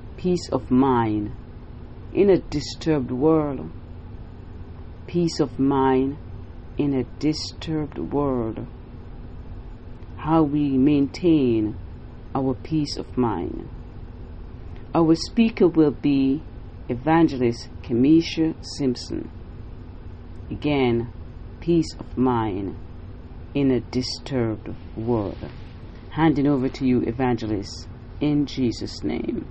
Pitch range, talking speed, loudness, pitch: 95-140 Hz, 90 wpm, -23 LUFS, 120 Hz